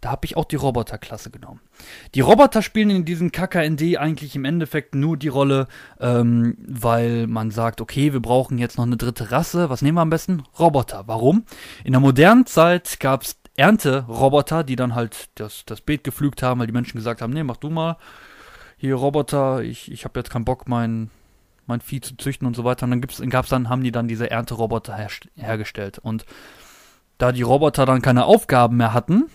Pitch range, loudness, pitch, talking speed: 120-150 Hz, -19 LUFS, 130 Hz, 205 wpm